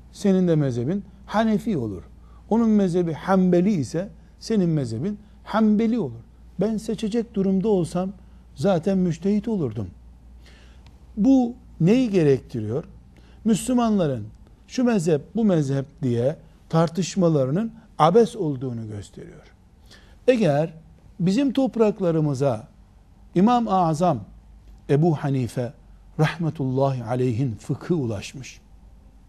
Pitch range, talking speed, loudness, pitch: 125-205 Hz, 90 wpm, -23 LUFS, 165 Hz